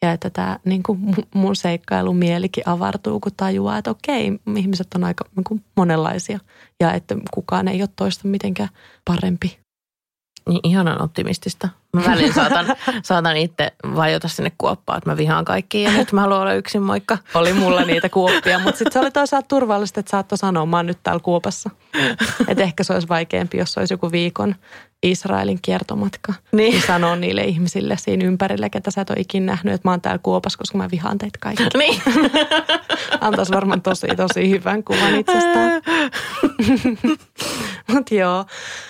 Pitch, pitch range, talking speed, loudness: 195 Hz, 175-215 Hz, 170 wpm, -19 LUFS